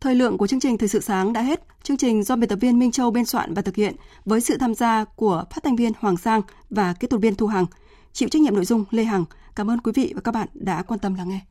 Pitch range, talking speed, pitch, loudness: 205-245 Hz, 305 wpm, 225 Hz, -22 LUFS